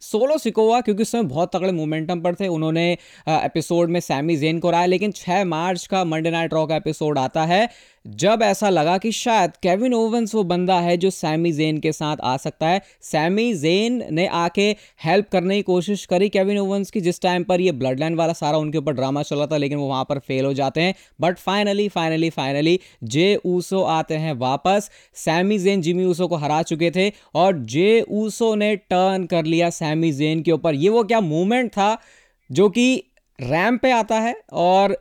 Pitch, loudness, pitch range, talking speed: 180 Hz, -20 LUFS, 160-200 Hz, 205 wpm